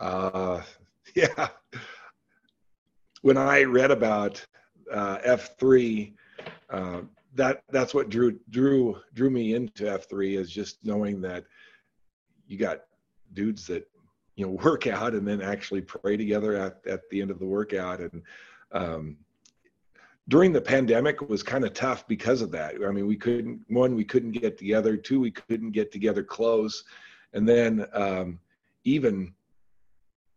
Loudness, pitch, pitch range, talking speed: -26 LUFS, 105 Hz, 95-115 Hz, 150 wpm